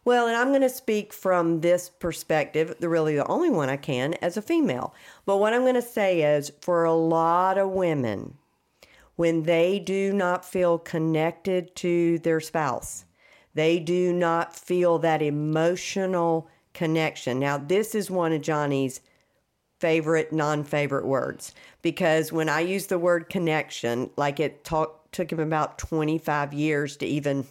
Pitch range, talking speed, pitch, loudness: 155-180 Hz, 160 wpm, 165 Hz, -25 LUFS